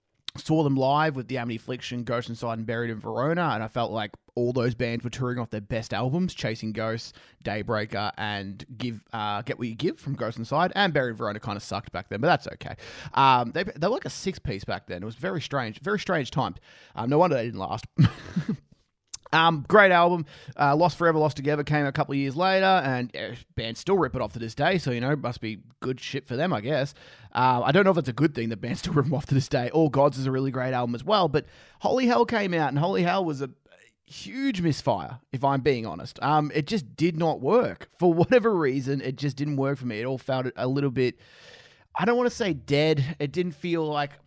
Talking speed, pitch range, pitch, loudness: 245 wpm, 120-160 Hz, 140 Hz, -26 LUFS